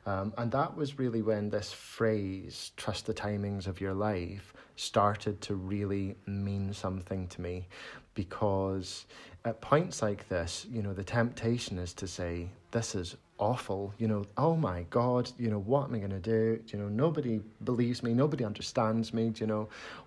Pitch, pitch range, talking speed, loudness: 105 Hz, 95-115 Hz, 180 wpm, -33 LUFS